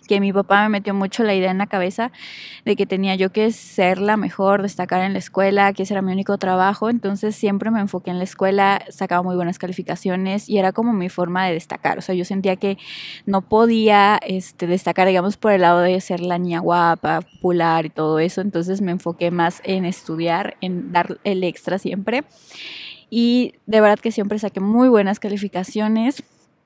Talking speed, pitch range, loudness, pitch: 200 wpm, 180-205 Hz, -19 LUFS, 195 Hz